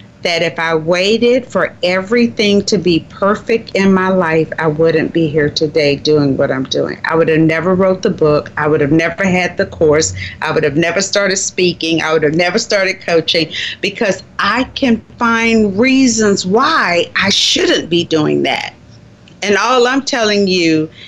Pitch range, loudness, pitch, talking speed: 160-205 Hz, -13 LUFS, 180 Hz, 180 wpm